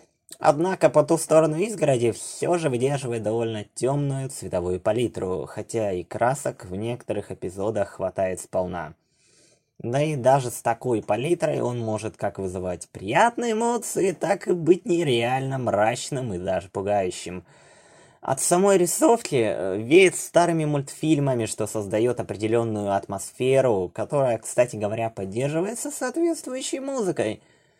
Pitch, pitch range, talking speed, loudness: 130 Hz, 105-165 Hz, 125 wpm, -24 LUFS